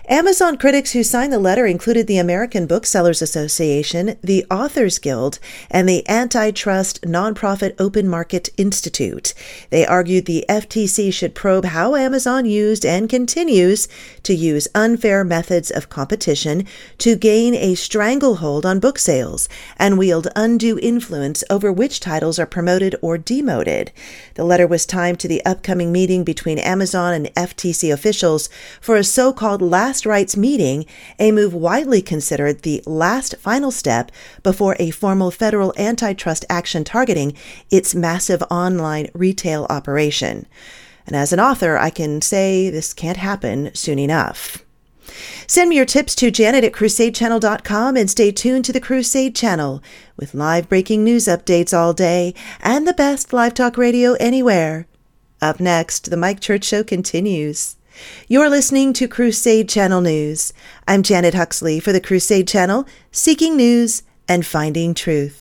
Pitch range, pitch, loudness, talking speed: 170-230 Hz, 190 Hz, -16 LUFS, 150 wpm